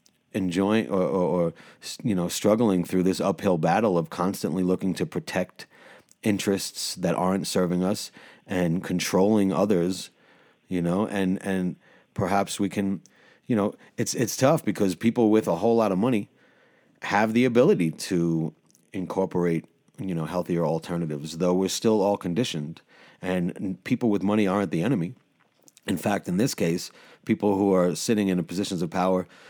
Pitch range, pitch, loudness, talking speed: 90-105 Hz, 95 Hz, -25 LUFS, 160 wpm